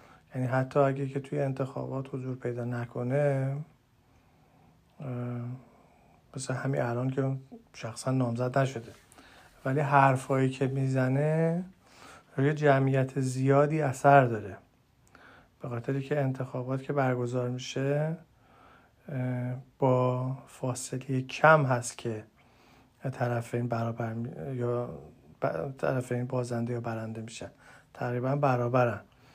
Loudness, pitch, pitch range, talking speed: -29 LUFS, 130 Hz, 120-135 Hz, 100 wpm